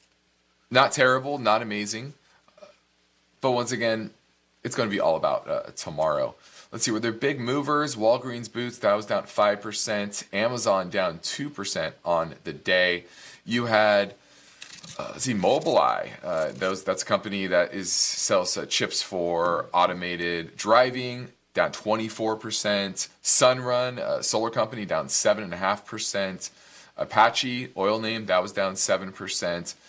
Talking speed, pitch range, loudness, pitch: 155 wpm, 90-120 Hz, -25 LUFS, 105 Hz